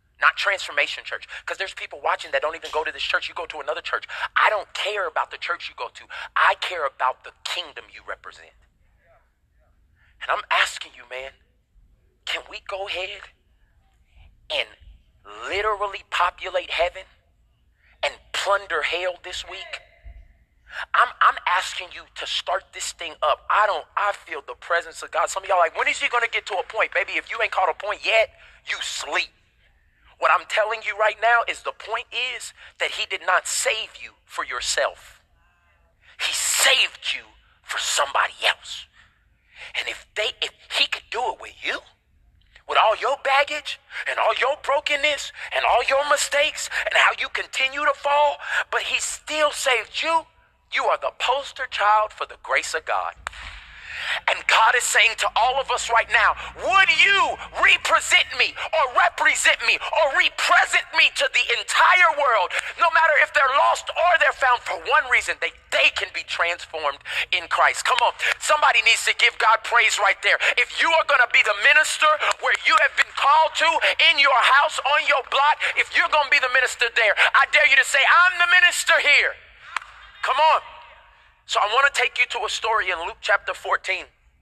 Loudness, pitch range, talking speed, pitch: -20 LUFS, 205-305 Hz, 185 wpm, 265 Hz